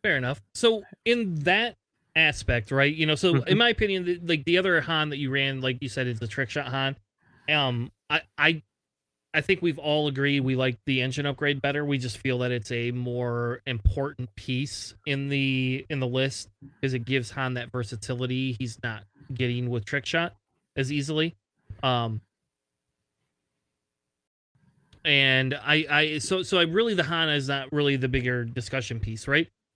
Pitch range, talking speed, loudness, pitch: 125-150 Hz, 180 wpm, -26 LUFS, 135 Hz